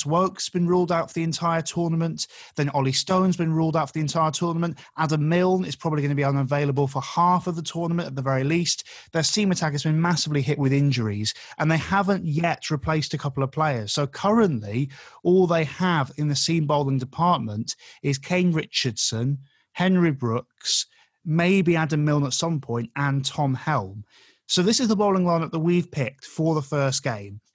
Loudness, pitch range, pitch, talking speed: -23 LUFS, 140-170 Hz, 155 Hz, 195 wpm